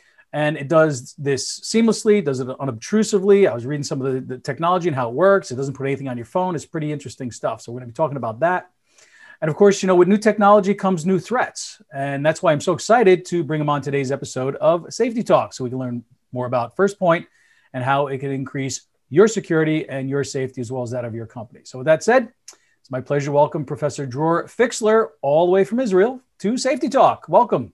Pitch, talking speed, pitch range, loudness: 150 Hz, 240 wpm, 135-195 Hz, -20 LUFS